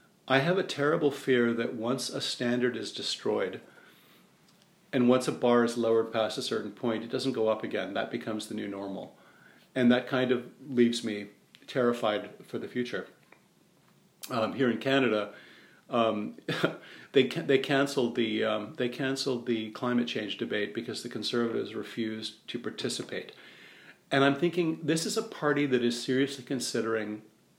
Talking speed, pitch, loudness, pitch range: 165 wpm, 125 Hz, -30 LUFS, 115-135 Hz